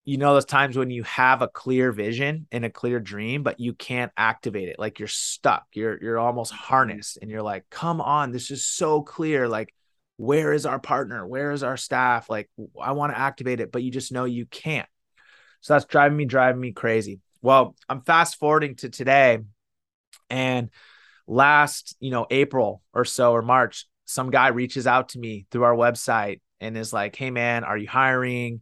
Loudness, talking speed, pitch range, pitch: -23 LUFS, 200 wpm, 115-135 Hz, 125 Hz